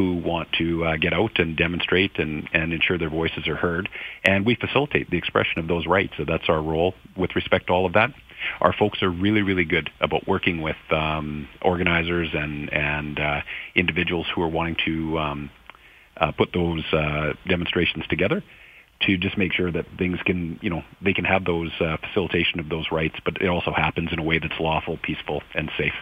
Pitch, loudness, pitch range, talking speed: 85 Hz, -23 LUFS, 80-90 Hz, 205 wpm